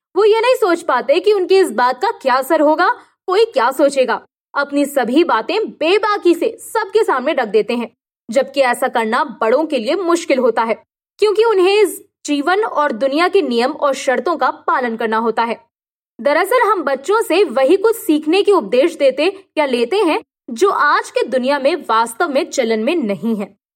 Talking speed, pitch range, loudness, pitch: 185 wpm, 255-395 Hz, -15 LUFS, 305 Hz